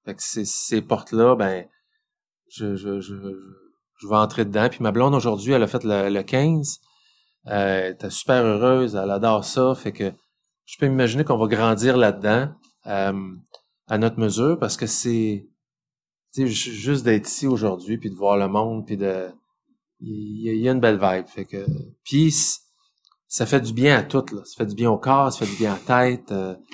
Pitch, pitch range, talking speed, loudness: 115 Hz, 100-135 Hz, 210 wpm, -21 LUFS